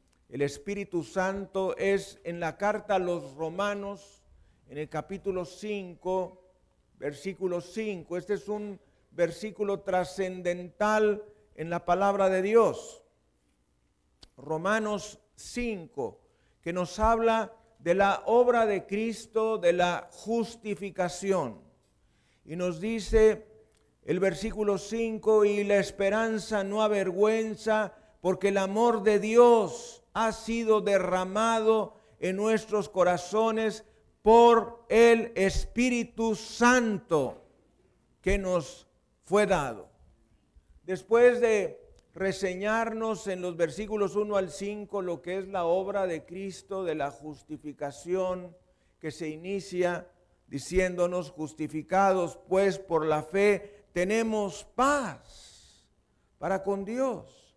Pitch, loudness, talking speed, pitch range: 195 Hz, -28 LUFS, 105 wpm, 175-215 Hz